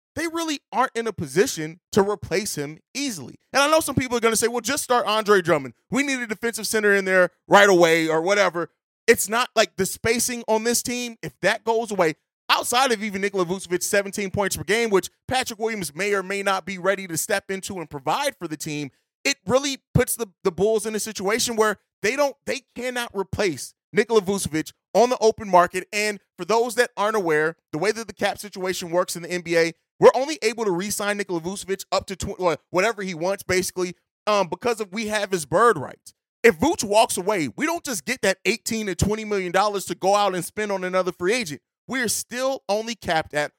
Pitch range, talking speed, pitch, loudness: 185-230 Hz, 220 wpm, 205 Hz, -22 LUFS